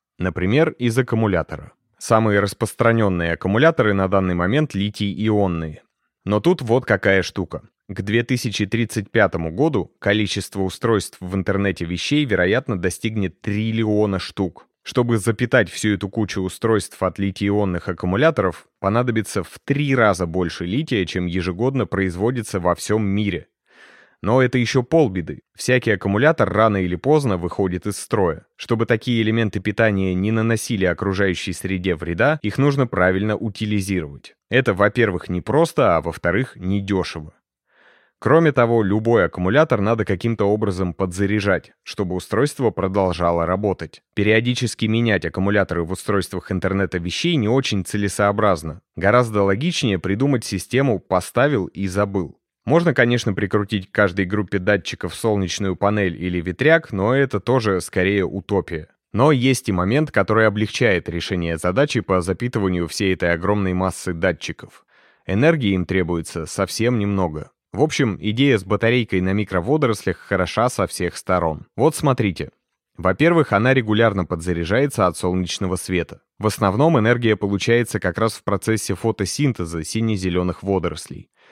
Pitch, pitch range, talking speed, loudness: 100 Hz, 95-115 Hz, 130 wpm, -20 LUFS